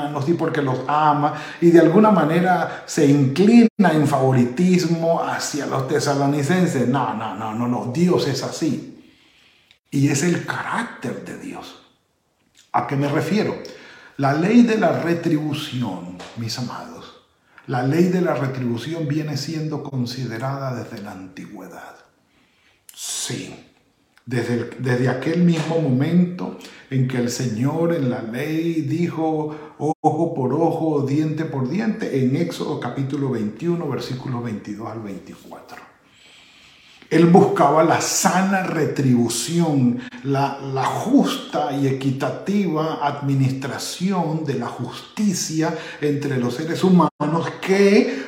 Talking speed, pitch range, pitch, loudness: 125 wpm, 130-165 Hz, 150 Hz, -20 LUFS